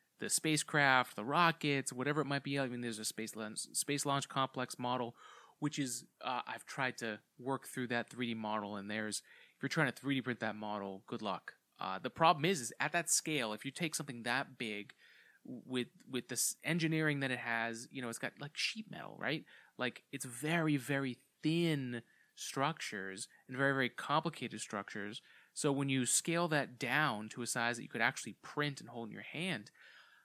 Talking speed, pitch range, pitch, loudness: 200 wpm, 120-150 Hz, 130 Hz, -37 LUFS